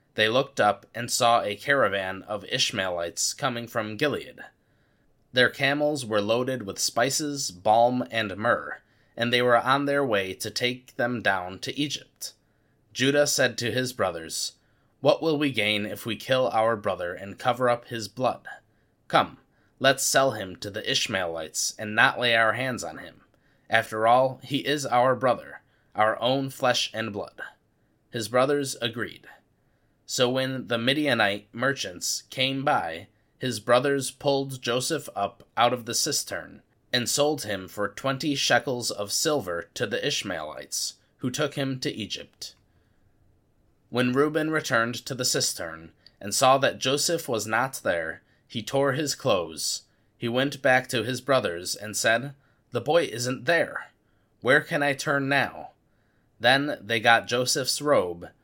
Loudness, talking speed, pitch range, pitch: -25 LUFS, 155 wpm, 110-135 Hz, 125 Hz